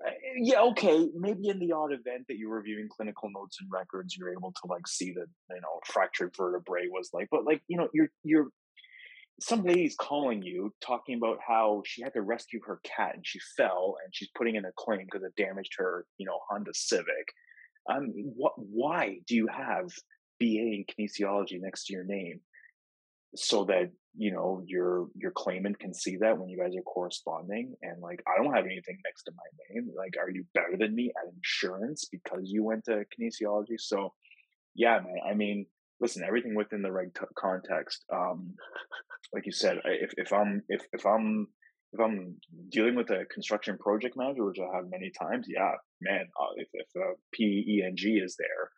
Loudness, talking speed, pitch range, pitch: -32 LUFS, 195 wpm, 95-155 Hz, 110 Hz